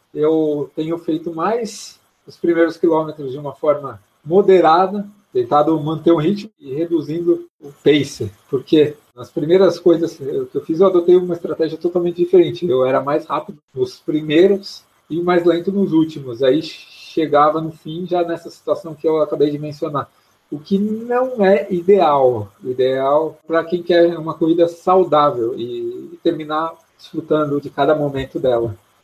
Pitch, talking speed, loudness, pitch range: 165 Hz, 155 wpm, -17 LUFS, 150-180 Hz